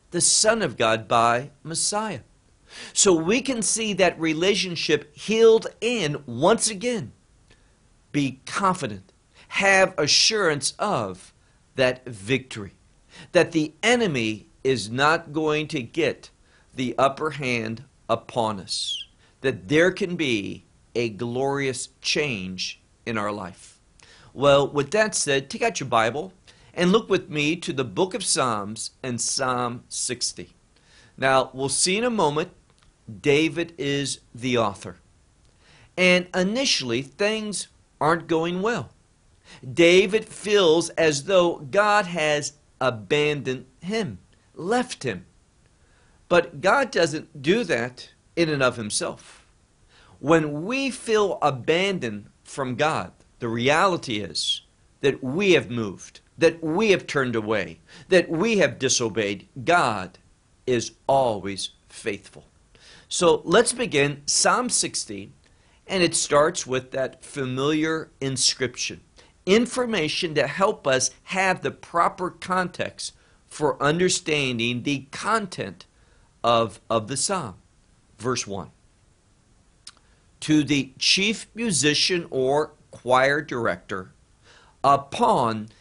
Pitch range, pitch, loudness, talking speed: 115-175 Hz, 140 Hz, -23 LUFS, 115 wpm